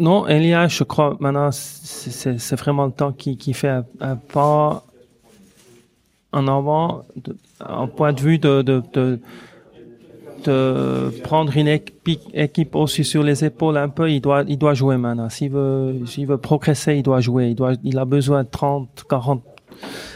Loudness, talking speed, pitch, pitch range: -19 LUFS, 170 wpm, 140 Hz, 130-150 Hz